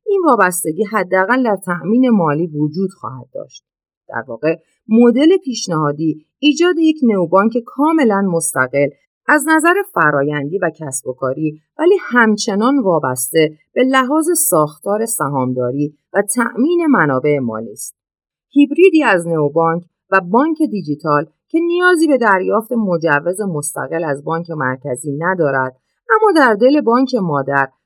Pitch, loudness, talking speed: 190 Hz, -15 LUFS, 125 wpm